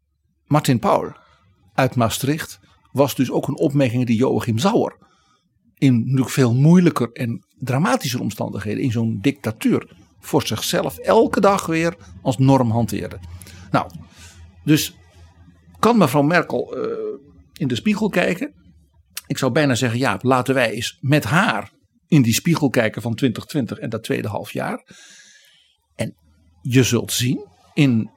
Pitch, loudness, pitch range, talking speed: 130 Hz, -19 LUFS, 100-145 Hz, 140 wpm